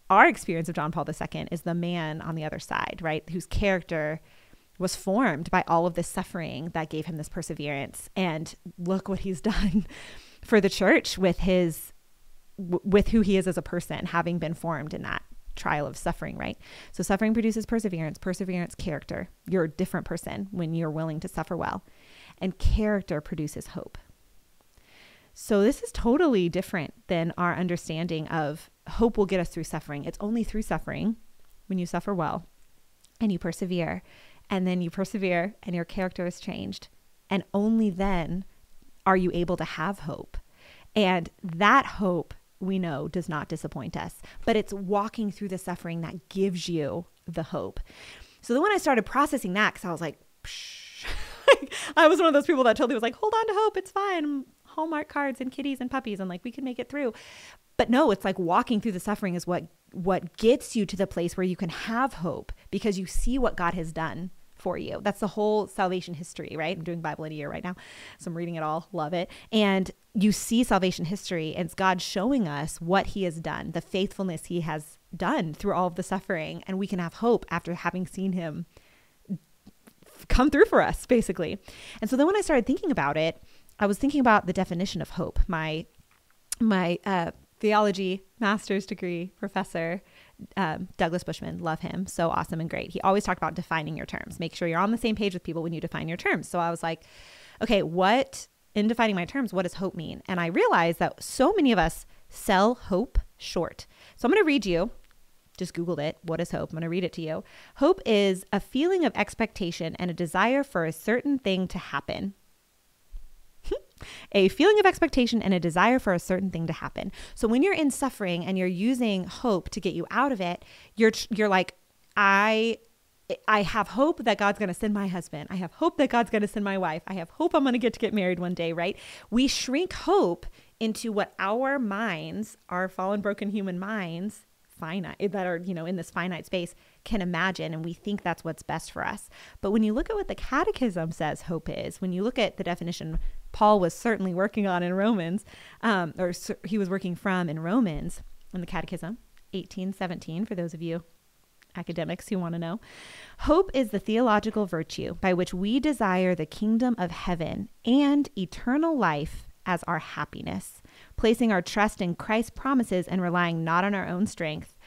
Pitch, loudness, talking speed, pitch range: 190 Hz, -27 LUFS, 200 wpm, 170-215 Hz